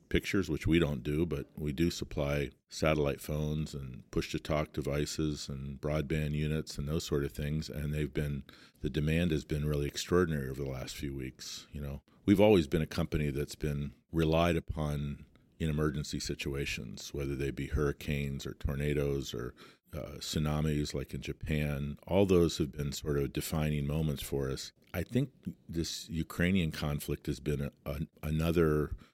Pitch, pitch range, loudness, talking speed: 75 Hz, 70-80 Hz, -34 LUFS, 175 wpm